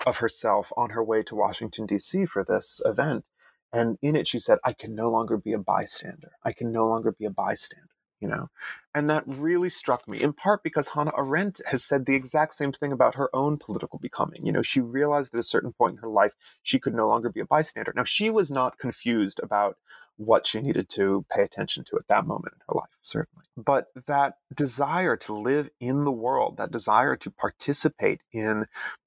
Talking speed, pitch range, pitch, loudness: 215 wpm, 115-155 Hz, 140 Hz, -26 LUFS